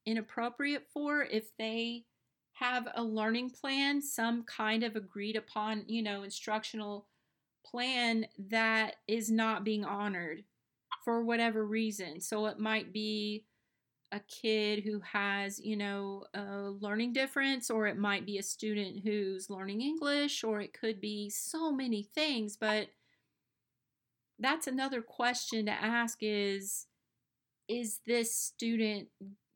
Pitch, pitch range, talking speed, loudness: 220 Hz, 205-235 Hz, 130 wpm, -35 LUFS